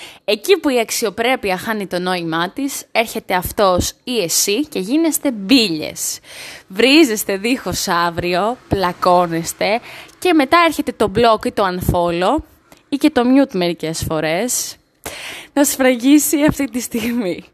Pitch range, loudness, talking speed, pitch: 180-280 Hz, -16 LUFS, 130 wpm, 230 Hz